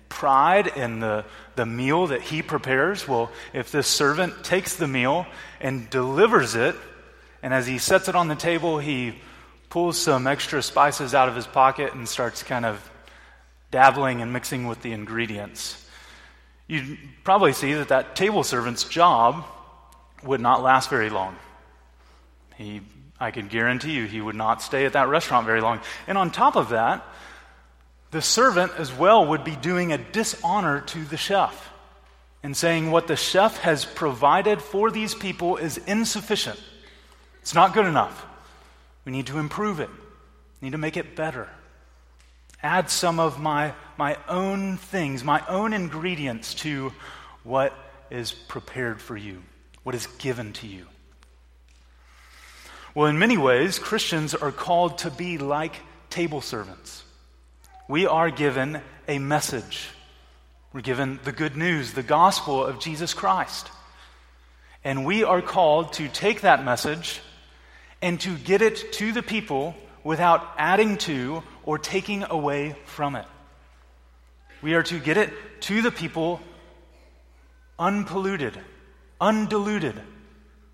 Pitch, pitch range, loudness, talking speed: 140 Hz, 105-170 Hz, -23 LUFS, 145 wpm